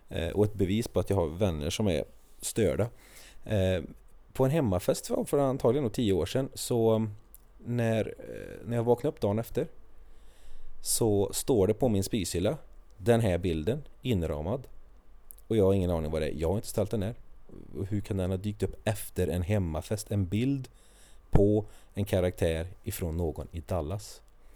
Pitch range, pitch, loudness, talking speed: 90-115 Hz, 100 Hz, -30 LUFS, 165 wpm